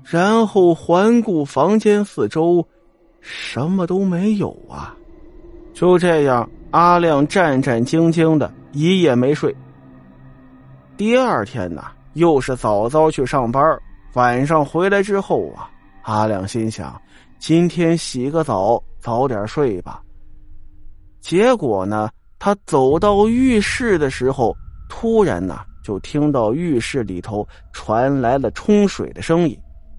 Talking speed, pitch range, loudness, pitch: 180 characters per minute, 105-180 Hz, -17 LUFS, 145 Hz